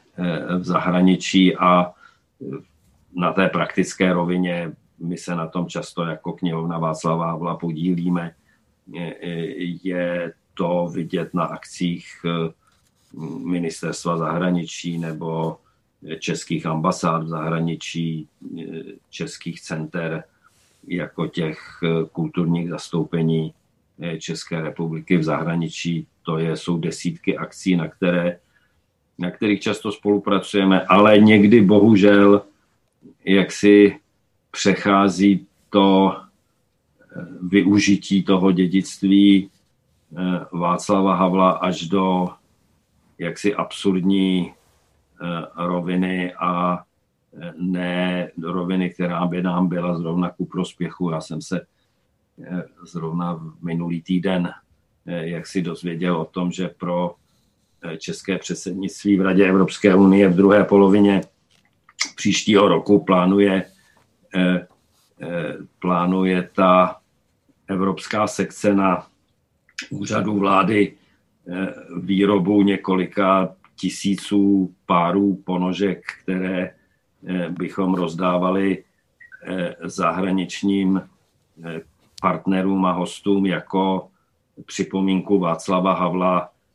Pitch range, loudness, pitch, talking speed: 85-95 Hz, -20 LUFS, 90 Hz, 90 wpm